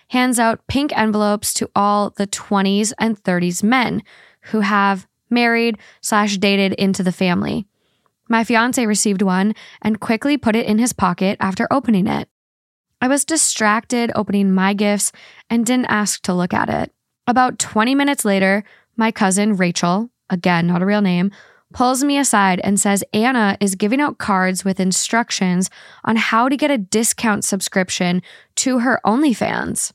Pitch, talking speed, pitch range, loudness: 210 Hz, 160 wpm, 195-235 Hz, -17 LUFS